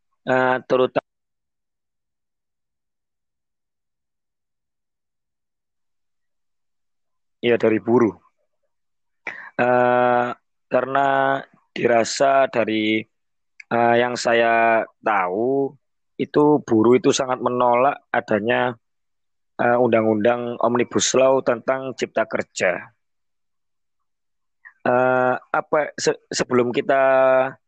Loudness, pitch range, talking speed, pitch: -19 LUFS, 115-130 Hz, 65 wpm, 125 Hz